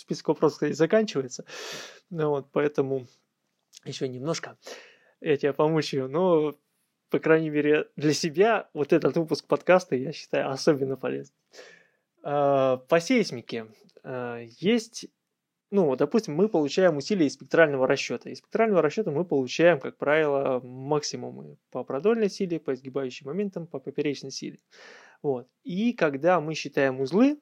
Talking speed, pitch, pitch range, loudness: 135 wpm, 150 Hz, 135-175 Hz, -26 LUFS